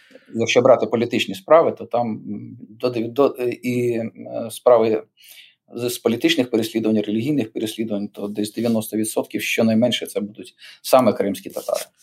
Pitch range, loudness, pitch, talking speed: 110-120 Hz, -20 LUFS, 115 Hz, 110 wpm